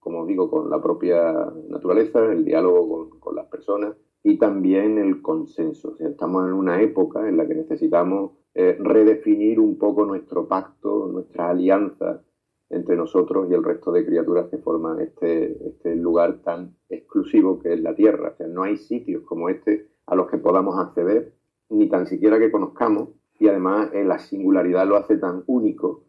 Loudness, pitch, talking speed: -21 LUFS, 105 Hz, 180 wpm